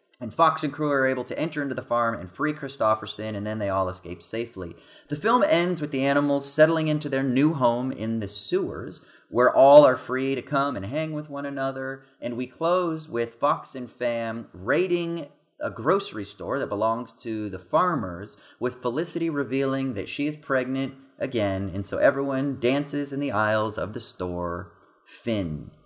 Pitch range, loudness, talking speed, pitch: 110-145 Hz, -25 LUFS, 185 wpm, 130 Hz